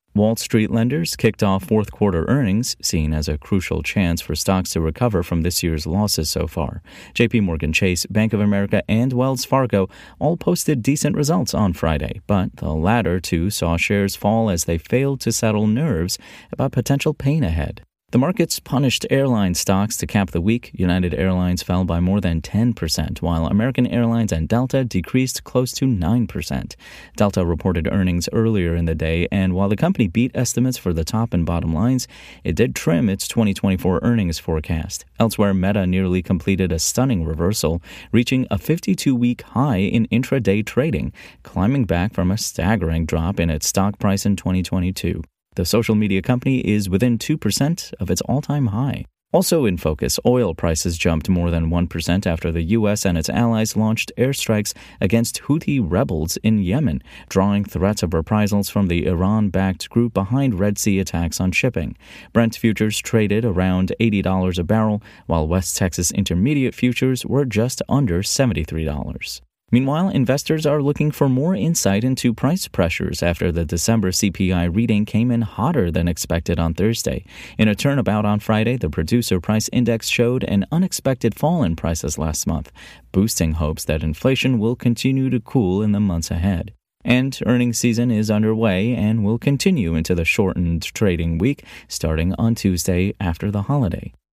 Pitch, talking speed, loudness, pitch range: 100 Hz, 170 wpm, -20 LUFS, 85-120 Hz